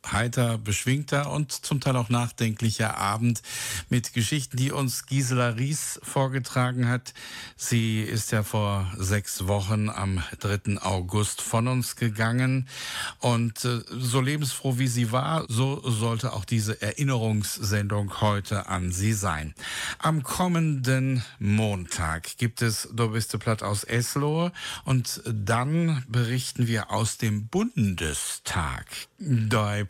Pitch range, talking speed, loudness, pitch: 105-130 Hz, 120 wpm, -27 LUFS, 115 Hz